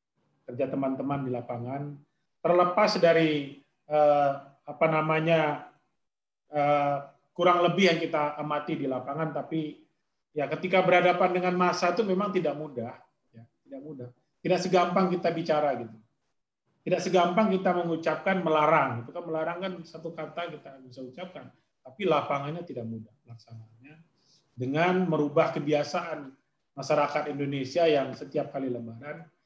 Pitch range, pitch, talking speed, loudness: 140-175 Hz, 155 Hz, 125 wpm, -27 LUFS